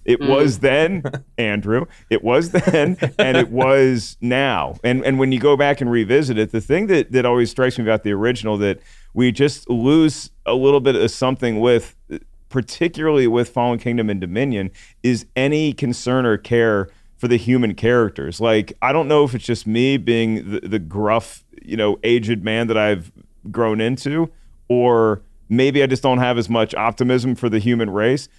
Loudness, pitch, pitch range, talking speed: -18 LUFS, 120 Hz, 110-135 Hz, 185 wpm